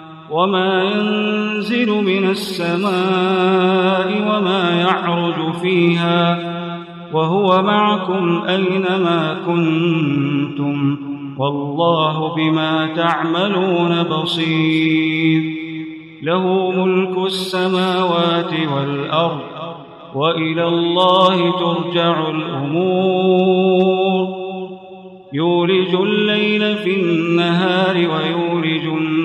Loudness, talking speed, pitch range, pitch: -16 LUFS, 55 wpm, 160-185 Hz, 175 Hz